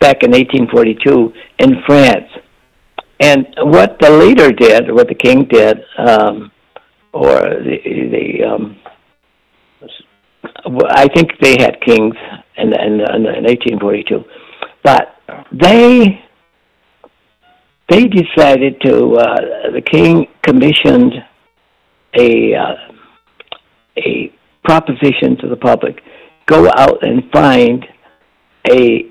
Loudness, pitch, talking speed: -9 LUFS, 145 Hz, 100 wpm